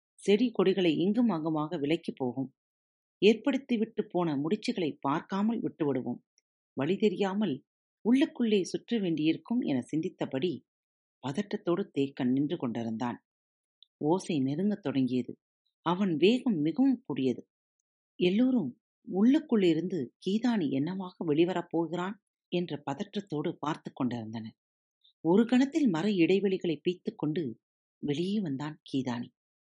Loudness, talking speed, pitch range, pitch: -30 LUFS, 95 wpm, 150-210 Hz, 180 Hz